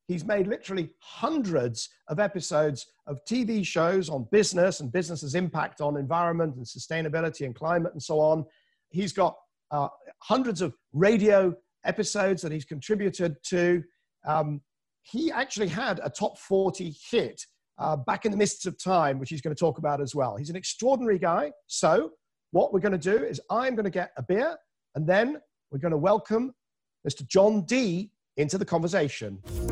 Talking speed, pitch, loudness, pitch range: 175 wpm, 175 Hz, -27 LUFS, 150-205 Hz